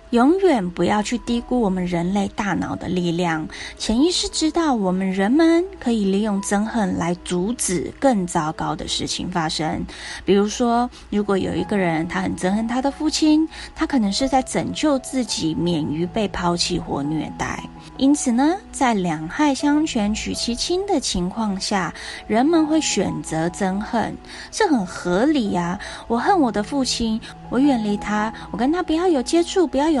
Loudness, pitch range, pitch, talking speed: -21 LUFS, 185-280 Hz, 230 Hz, 250 characters per minute